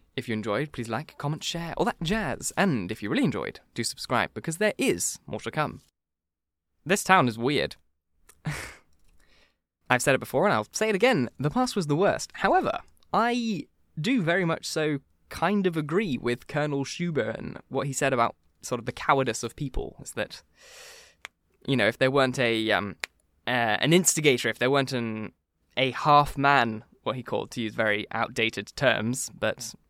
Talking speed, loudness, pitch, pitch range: 185 wpm, -26 LUFS, 130 Hz, 110-165 Hz